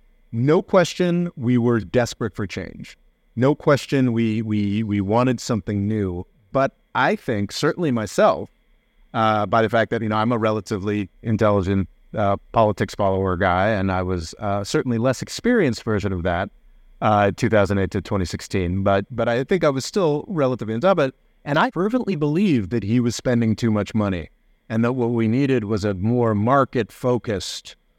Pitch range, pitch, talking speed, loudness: 100-125 Hz, 110 Hz, 175 wpm, -21 LUFS